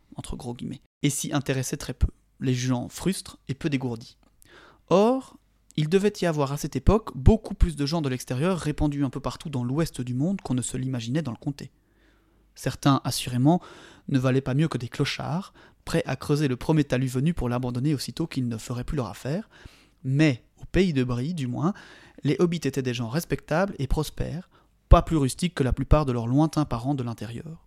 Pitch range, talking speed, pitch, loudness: 125-160 Hz, 205 wpm, 140 Hz, -26 LUFS